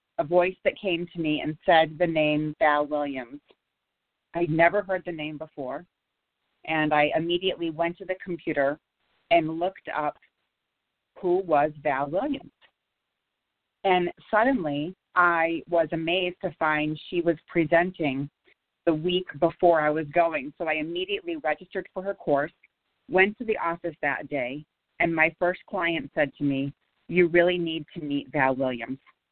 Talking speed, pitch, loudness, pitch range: 155 wpm, 170 Hz, -26 LUFS, 150-185 Hz